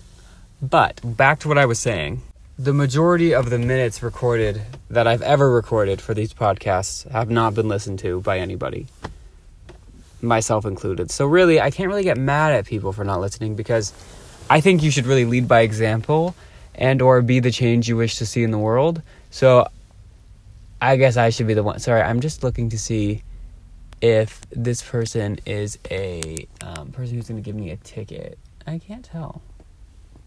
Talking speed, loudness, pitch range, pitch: 185 wpm, -19 LUFS, 100-130 Hz, 115 Hz